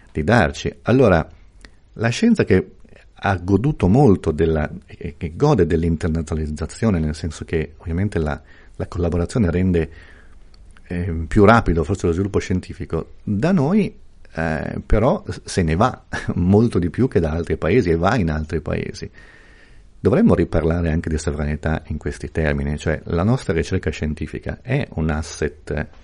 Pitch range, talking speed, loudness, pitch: 80-95 Hz, 145 wpm, -20 LUFS, 85 Hz